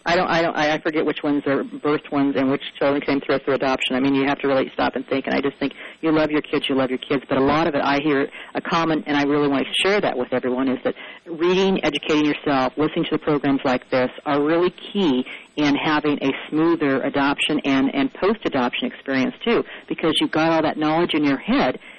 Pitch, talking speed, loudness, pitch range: 145 Hz, 250 wpm, -21 LUFS, 135-160 Hz